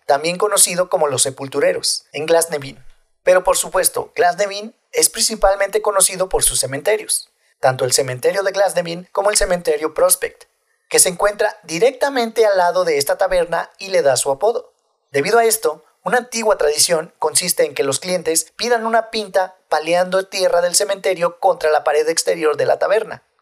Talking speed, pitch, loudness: 165 wpm, 205 Hz, -17 LUFS